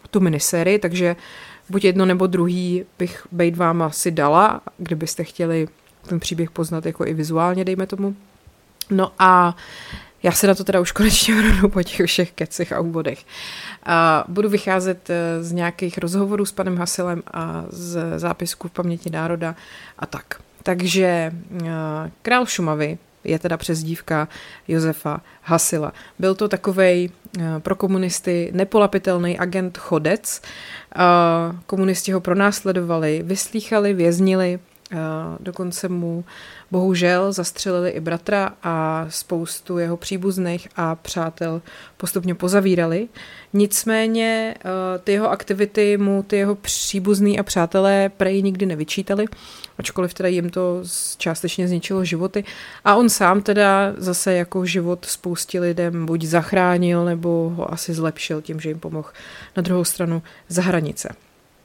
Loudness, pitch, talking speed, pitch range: -20 LUFS, 180 Hz, 130 wpm, 170-195 Hz